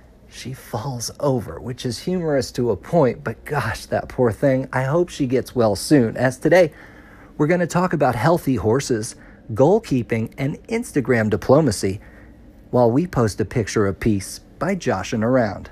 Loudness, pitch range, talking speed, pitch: -20 LUFS, 110-145 Hz, 165 wpm, 125 Hz